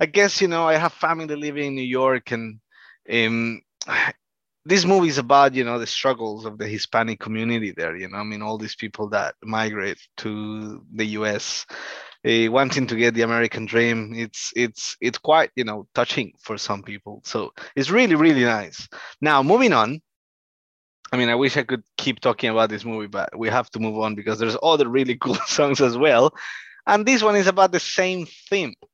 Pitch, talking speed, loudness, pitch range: 115 Hz, 200 wpm, -21 LUFS, 110-145 Hz